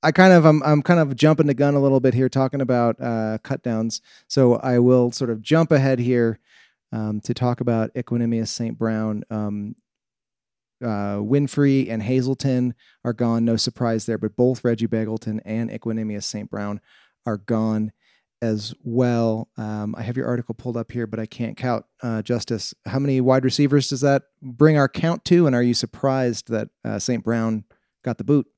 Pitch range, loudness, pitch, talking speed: 110-135 Hz, -21 LUFS, 120 Hz, 190 wpm